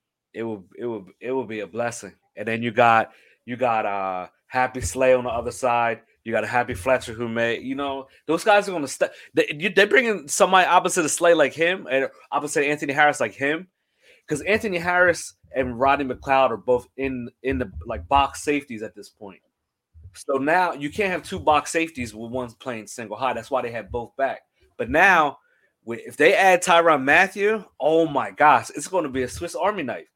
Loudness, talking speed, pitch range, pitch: -21 LUFS, 210 wpm, 115-165 Hz, 130 Hz